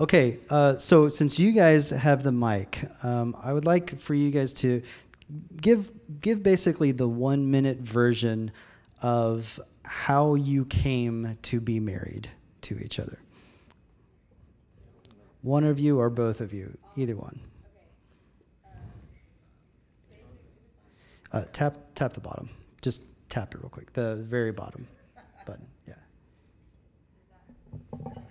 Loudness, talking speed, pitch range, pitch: -26 LUFS, 125 wpm, 115-145 Hz, 125 Hz